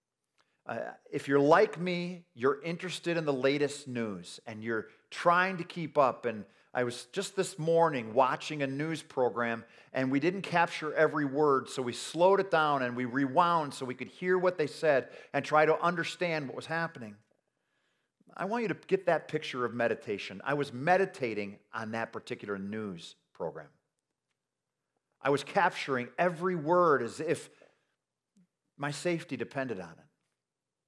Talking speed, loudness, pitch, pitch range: 165 wpm, -31 LUFS, 145 Hz, 125-170 Hz